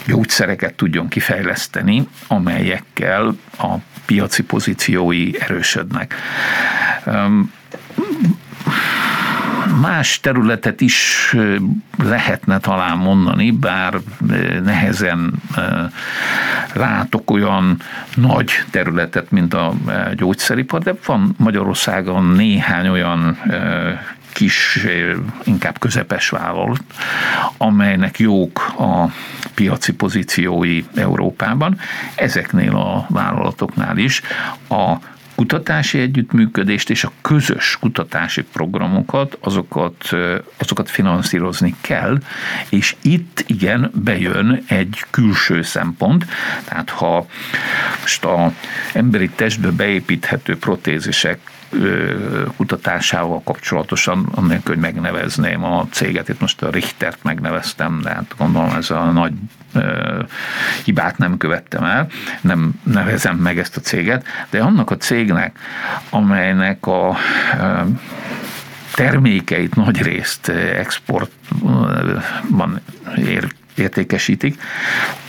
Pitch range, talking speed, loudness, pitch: 90-145 Hz, 85 wpm, -16 LUFS, 100 Hz